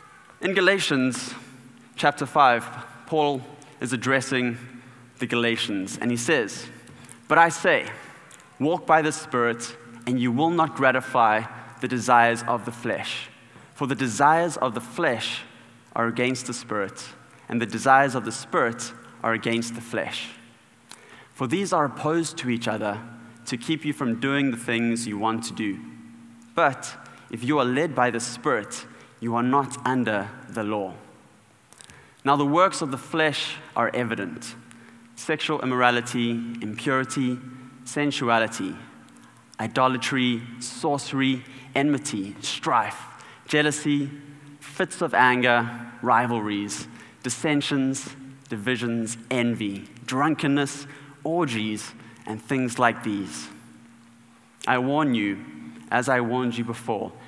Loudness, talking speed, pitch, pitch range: -24 LUFS, 125 wpm, 125 Hz, 115-140 Hz